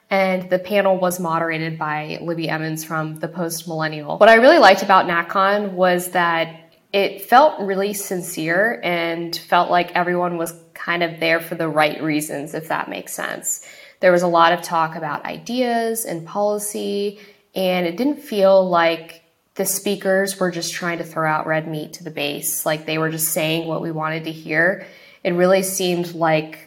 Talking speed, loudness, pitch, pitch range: 185 wpm, -19 LUFS, 175 Hz, 160-195 Hz